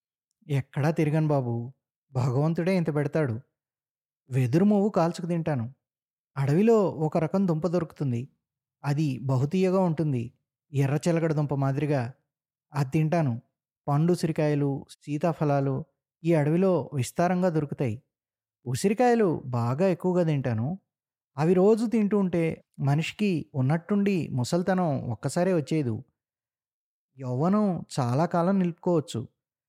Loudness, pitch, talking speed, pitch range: -26 LUFS, 150 Hz, 95 wpm, 135-175 Hz